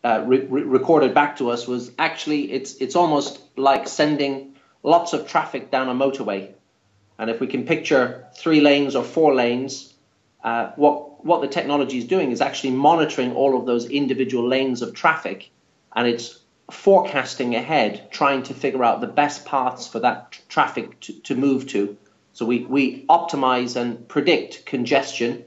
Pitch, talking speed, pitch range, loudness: 135 Hz, 170 wpm, 120-145 Hz, -21 LUFS